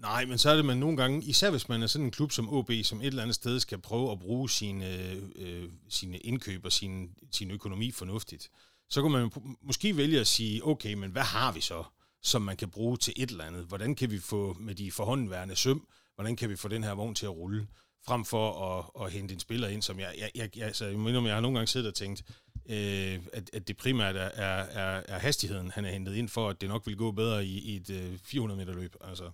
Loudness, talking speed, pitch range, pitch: -32 LUFS, 245 wpm, 95-120 Hz, 110 Hz